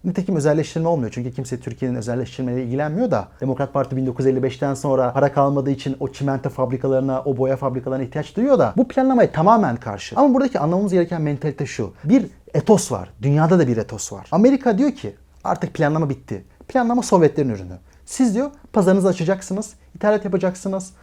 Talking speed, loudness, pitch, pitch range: 165 wpm, -20 LUFS, 145 Hz, 130-195 Hz